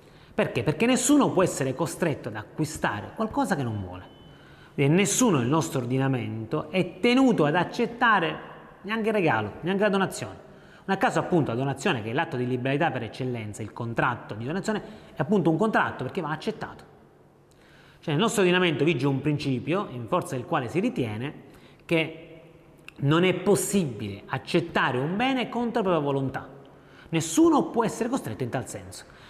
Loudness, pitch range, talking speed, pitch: -26 LUFS, 130-195 Hz, 165 wpm, 160 Hz